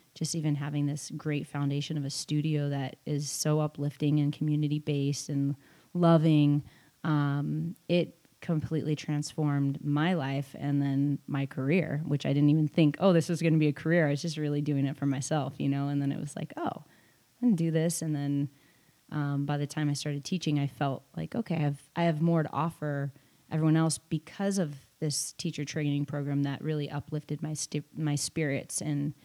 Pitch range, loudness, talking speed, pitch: 145-160 Hz, -30 LUFS, 195 wpm, 150 Hz